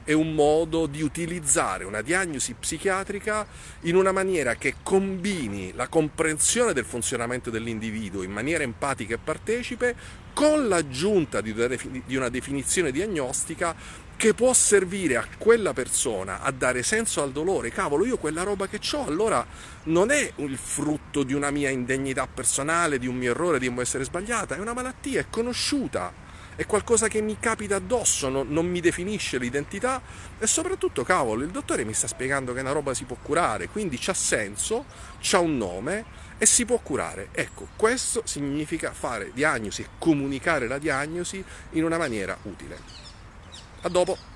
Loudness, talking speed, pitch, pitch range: -25 LUFS, 160 wpm, 165 Hz, 130-205 Hz